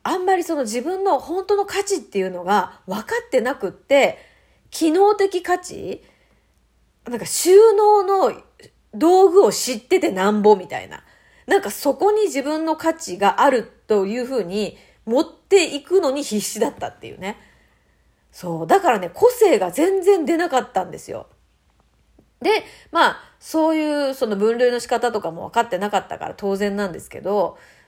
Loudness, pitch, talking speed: -19 LUFS, 305 Hz, 310 characters per minute